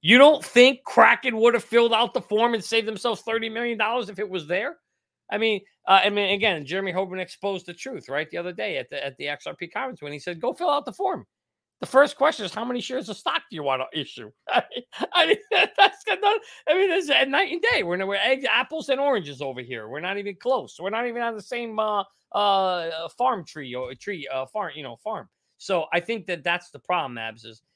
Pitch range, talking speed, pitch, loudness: 175-250 Hz, 245 wpm, 210 Hz, -23 LUFS